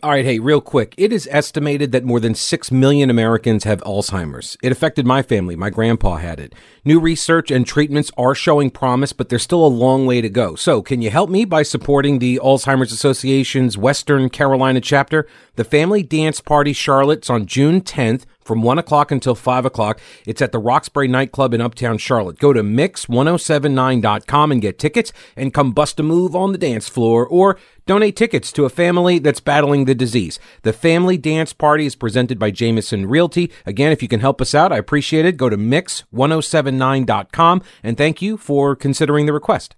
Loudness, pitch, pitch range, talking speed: -16 LUFS, 135 Hz, 120-155 Hz, 195 wpm